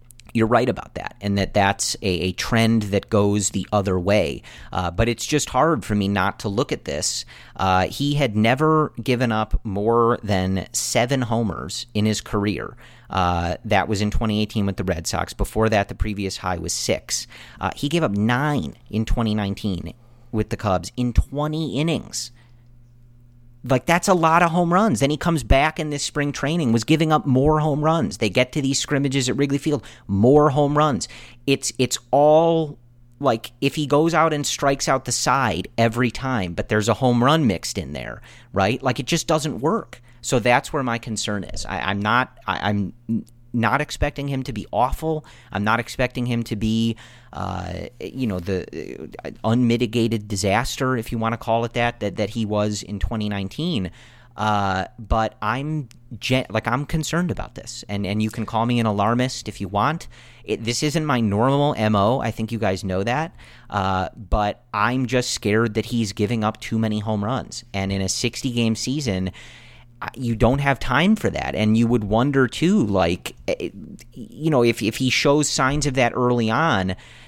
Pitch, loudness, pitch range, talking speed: 115 Hz, -21 LUFS, 105-135 Hz, 190 wpm